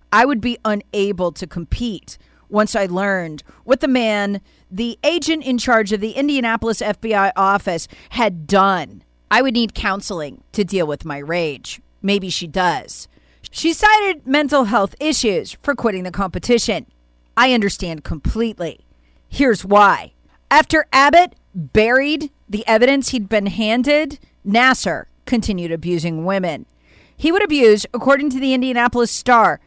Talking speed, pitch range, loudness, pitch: 140 wpm, 185-255 Hz, -17 LUFS, 215 Hz